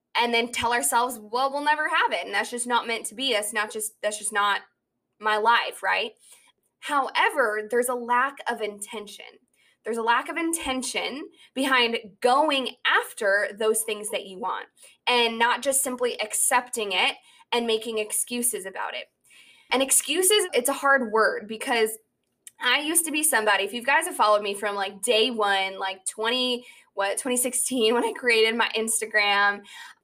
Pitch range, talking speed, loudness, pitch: 215-260 Hz, 170 wpm, -24 LUFS, 235 Hz